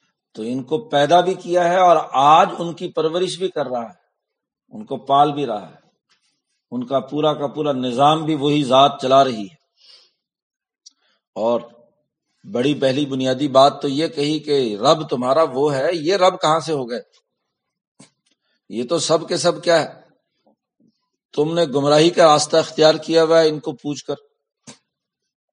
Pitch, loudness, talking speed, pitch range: 150 Hz, -18 LUFS, 170 wpm, 140-170 Hz